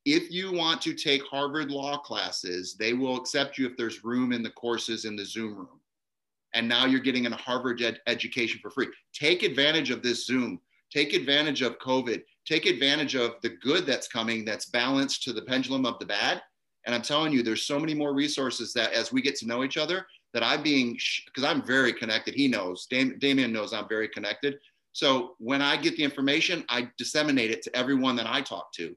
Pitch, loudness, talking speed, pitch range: 130 Hz, -27 LUFS, 215 wpm, 115-140 Hz